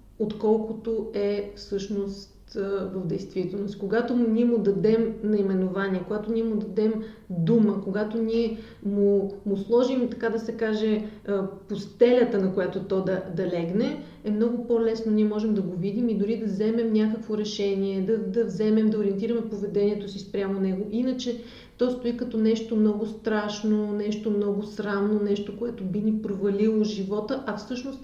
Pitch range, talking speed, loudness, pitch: 200-225 Hz, 155 wpm, -26 LUFS, 215 Hz